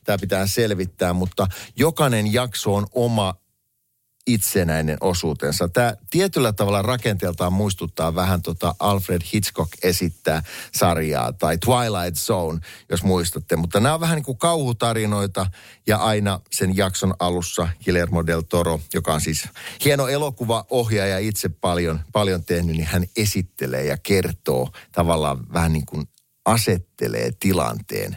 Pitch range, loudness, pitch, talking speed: 85-110 Hz, -21 LUFS, 95 Hz, 130 wpm